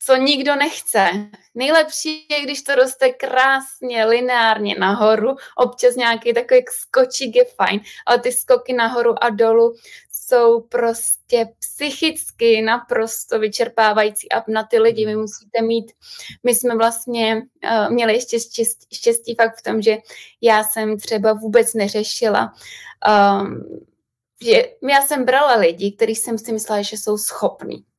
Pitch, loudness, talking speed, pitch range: 235 Hz, -17 LUFS, 140 wpm, 220-260 Hz